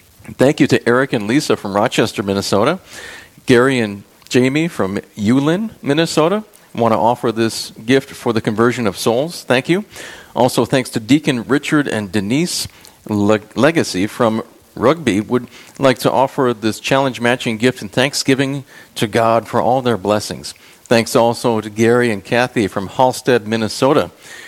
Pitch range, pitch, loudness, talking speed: 115-135 Hz, 120 Hz, -16 LUFS, 150 wpm